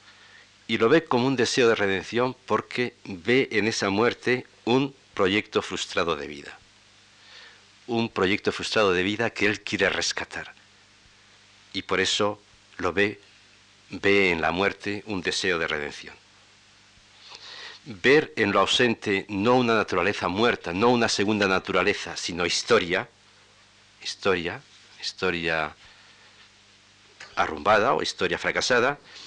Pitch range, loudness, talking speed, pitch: 100-115 Hz, -24 LUFS, 125 wpm, 100 Hz